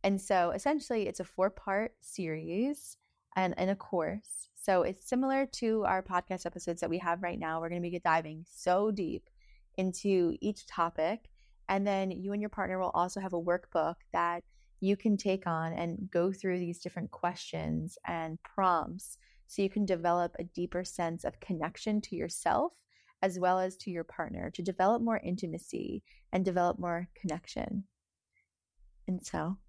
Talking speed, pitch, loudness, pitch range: 170 wpm, 185 Hz, -34 LUFS, 175-200 Hz